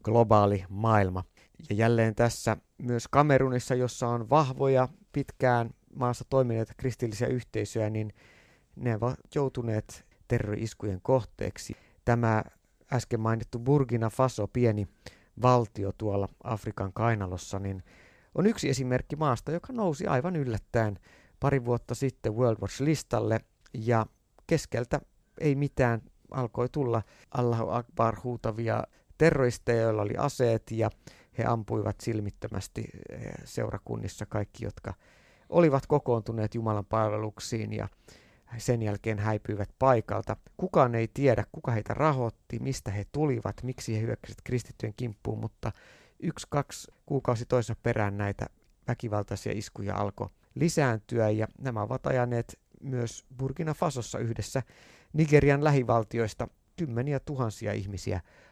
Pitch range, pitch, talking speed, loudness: 105-130 Hz, 115 Hz, 115 wpm, -30 LUFS